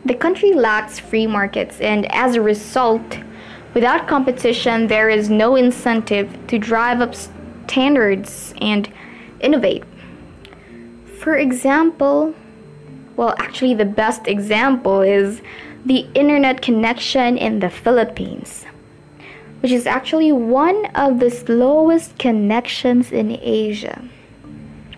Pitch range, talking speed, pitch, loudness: 215-260 Hz, 110 wpm, 235 Hz, -17 LUFS